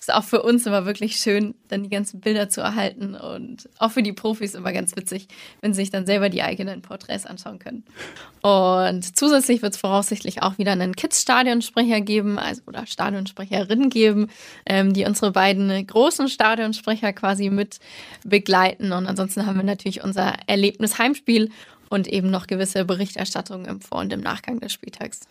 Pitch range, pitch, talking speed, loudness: 195-225 Hz, 205 Hz, 180 wpm, -21 LUFS